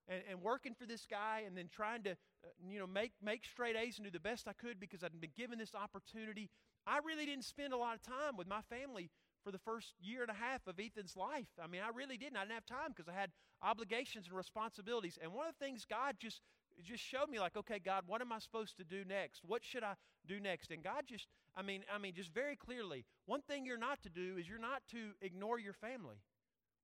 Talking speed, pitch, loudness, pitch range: 255 wpm, 215 Hz, -46 LUFS, 190-240 Hz